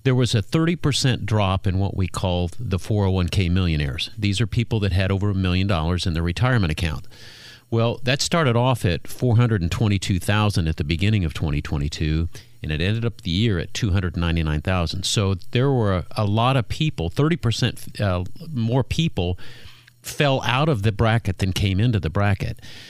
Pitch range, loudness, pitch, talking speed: 90-120 Hz, -22 LUFS, 105 Hz, 170 wpm